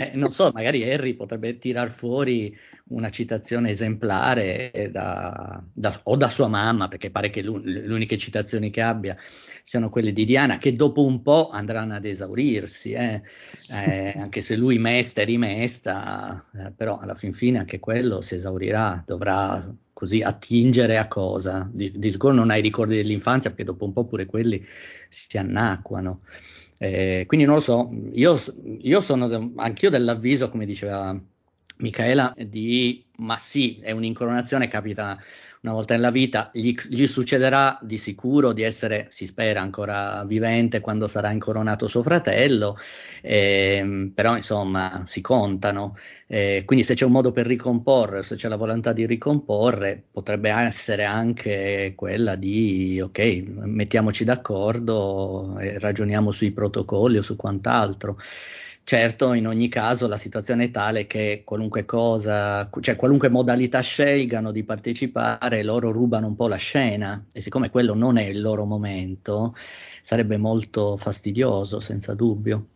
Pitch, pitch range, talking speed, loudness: 110 Hz, 100-120 Hz, 150 wpm, -23 LUFS